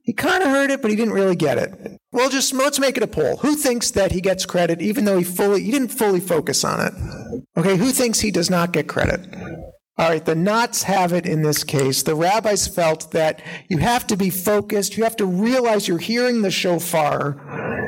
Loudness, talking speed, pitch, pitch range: -19 LUFS, 220 wpm, 195 Hz, 170-235 Hz